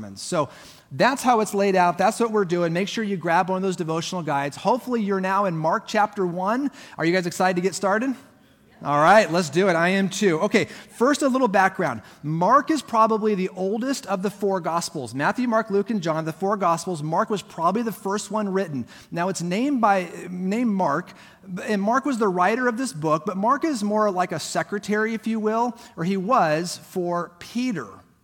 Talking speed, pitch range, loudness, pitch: 210 wpm, 175-220 Hz, -23 LUFS, 195 Hz